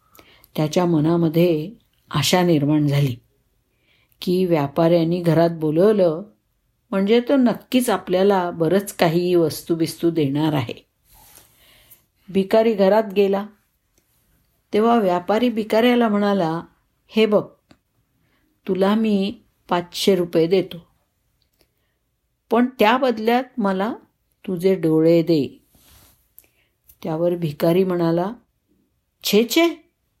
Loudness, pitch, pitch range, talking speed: -19 LUFS, 180 Hz, 160-210 Hz, 85 wpm